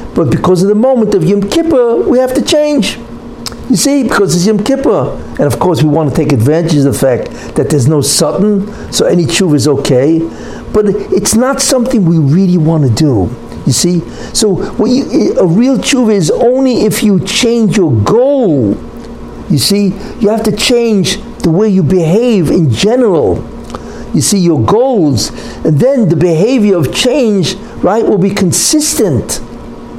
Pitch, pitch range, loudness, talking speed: 200 Hz, 165-235 Hz, -10 LUFS, 170 wpm